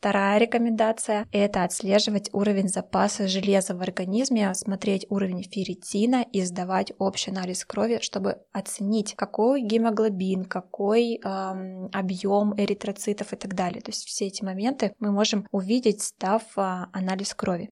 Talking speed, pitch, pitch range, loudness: 135 wpm, 200 Hz, 190-215 Hz, -26 LUFS